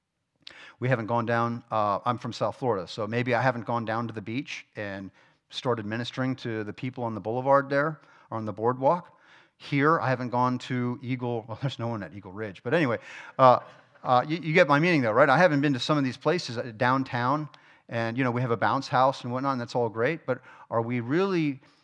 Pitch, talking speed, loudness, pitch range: 125 Hz, 230 wpm, -27 LUFS, 115-140 Hz